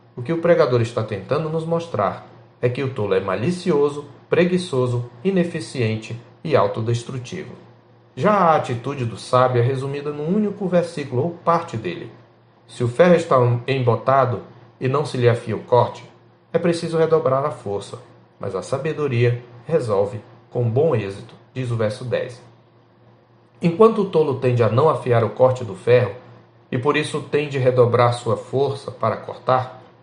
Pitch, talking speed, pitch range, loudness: 125 Hz, 160 wpm, 120-150 Hz, -20 LUFS